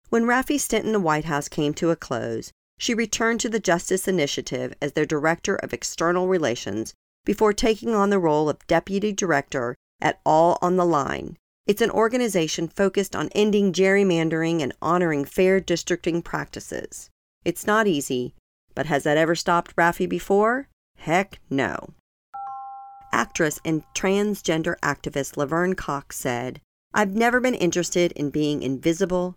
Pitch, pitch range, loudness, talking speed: 175 Hz, 150-205 Hz, -23 LUFS, 150 wpm